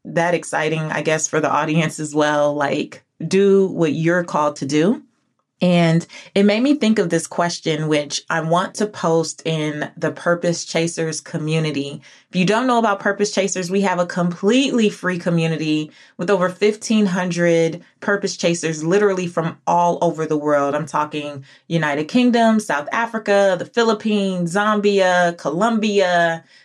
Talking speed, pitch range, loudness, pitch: 155 wpm, 160-200 Hz, -19 LUFS, 175 Hz